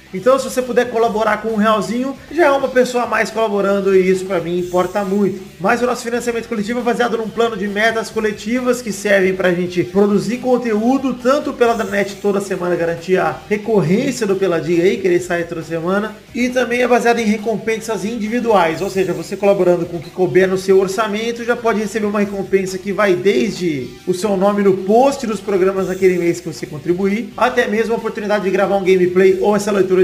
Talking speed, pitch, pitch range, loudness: 210 wpm, 205 Hz, 190-230 Hz, -16 LUFS